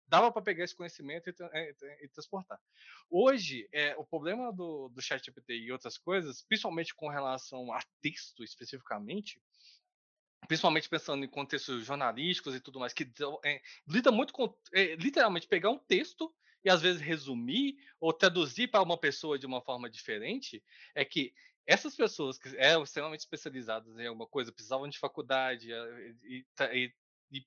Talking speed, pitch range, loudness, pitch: 165 wpm, 130-215 Hz, -33 LUFS, 155 Hz